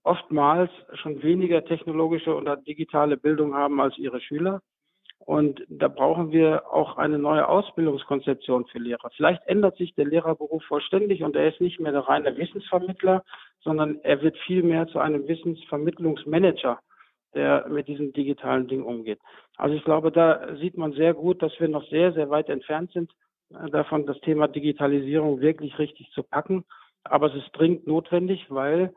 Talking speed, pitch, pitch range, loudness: 160 wpm, 155 Hz, 145-170 Hz, -24 LUFS